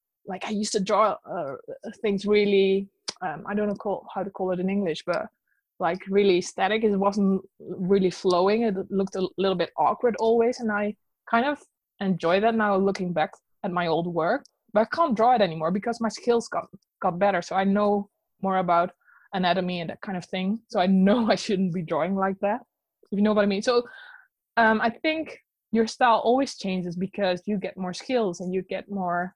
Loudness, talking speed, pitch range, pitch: -25 LUFS, 205 wpm, 185-225 Hz, 200 Hz